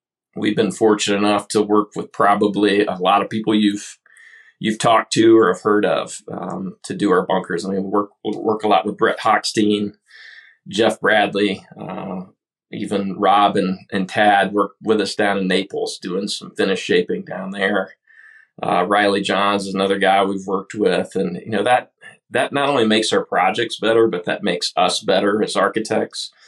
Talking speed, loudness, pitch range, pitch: 185 wpm, -18 LUFS, 95-105 Hz, 100 Hz